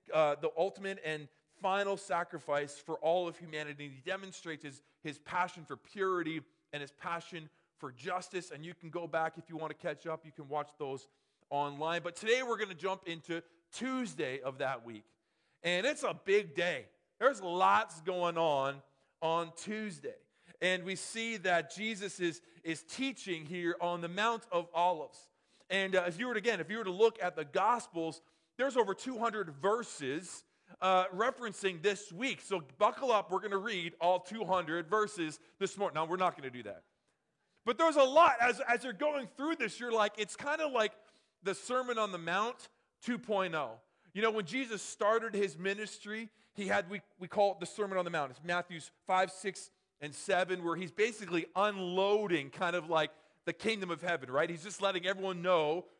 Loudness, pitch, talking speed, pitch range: -35 LUFS, 180 Hz, 190 wpm, 165-210 Hz